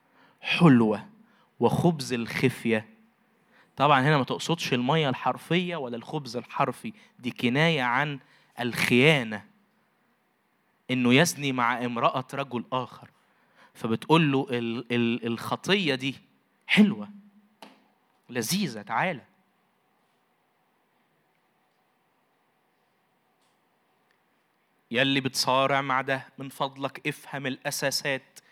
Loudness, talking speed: -26 LUFS, 80 wpm